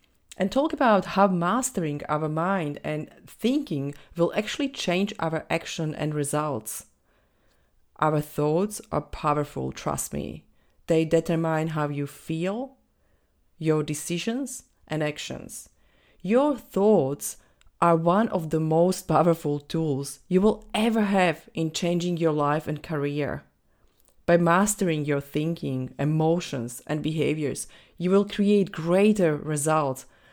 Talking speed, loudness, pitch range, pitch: 125 wpm, -25 LUFS, 145-190 Hz, 160 Hz